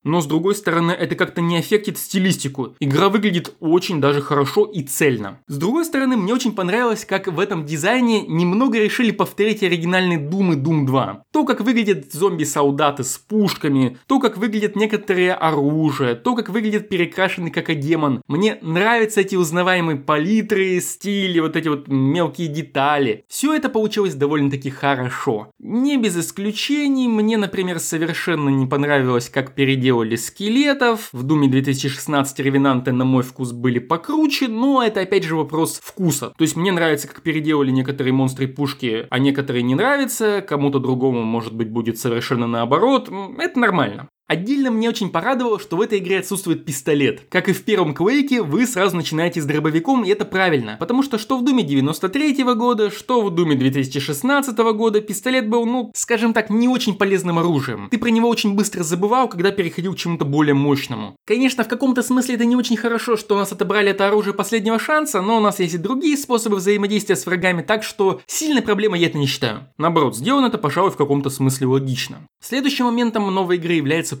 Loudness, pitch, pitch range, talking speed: -19 LUFS, 185 Hz, 145-220 Hz, 180 wpm